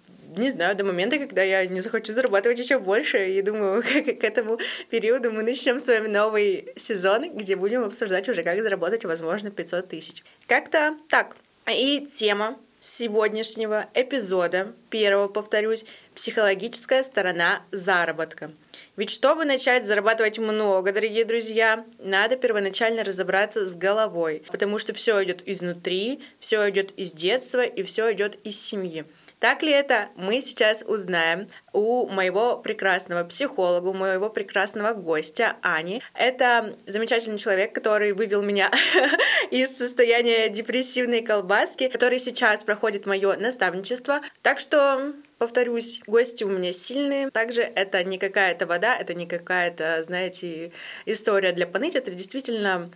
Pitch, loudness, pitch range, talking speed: 215 Hz, -23 LUFS, 190-240 Hz, 135 wpm